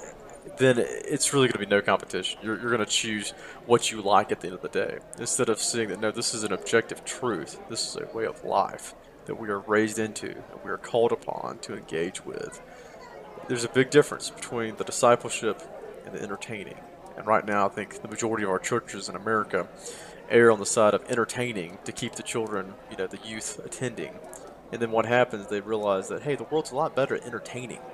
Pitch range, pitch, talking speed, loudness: 105-125 Hz, 115 Hz, 220 wpm, -27 LUFS